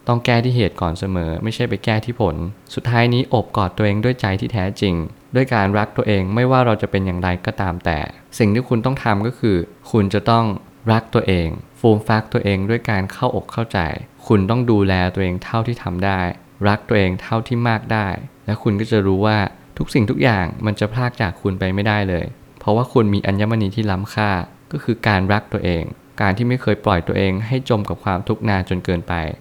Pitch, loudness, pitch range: 105 Hz, -19 LUFS, 95-115 Hz